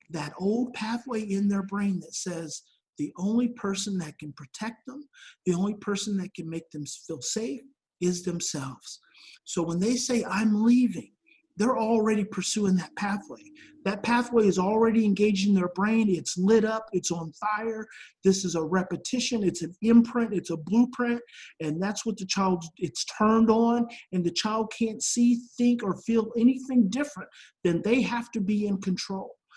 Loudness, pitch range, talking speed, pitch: -27 LUFS, 180-235 Hz, 175 wpm, 210 Hz